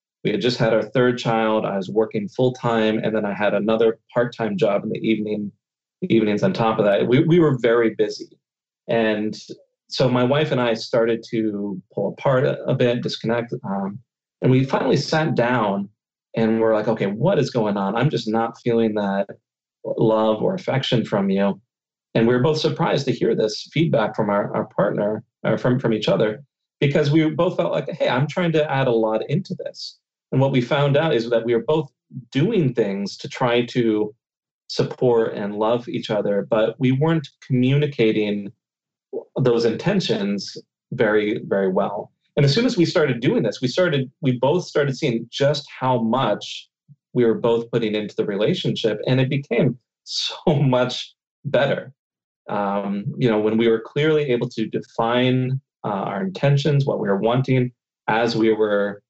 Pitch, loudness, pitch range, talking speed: 115 Hz, -21 LUFS, 110-140 Hz, 185 wpm